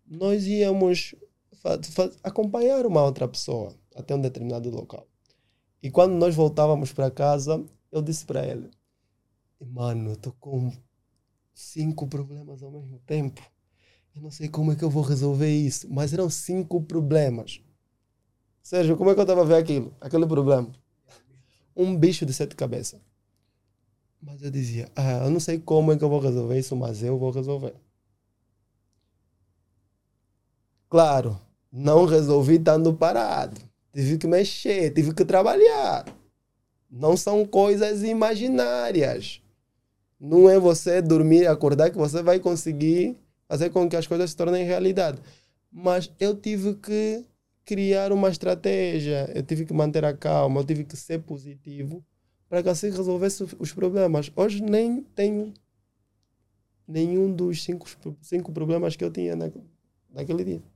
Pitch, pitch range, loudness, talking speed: 150 Hz, 120-180 Hz, -23 LUFS, 145 wpm